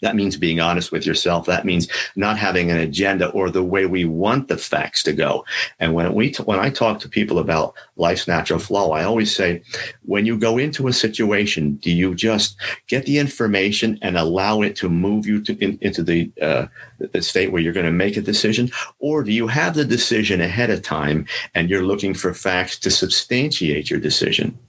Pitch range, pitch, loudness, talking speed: 90-115 Hz, 100 Hz, -19 LUFS, 210 wpm